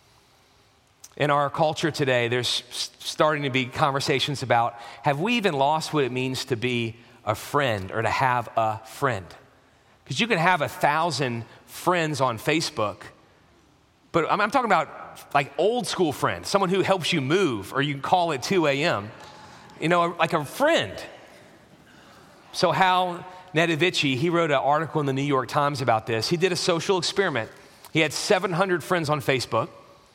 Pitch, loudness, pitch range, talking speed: 145 Hz, -24 LUFS, 125-170 Hz, 165 wpm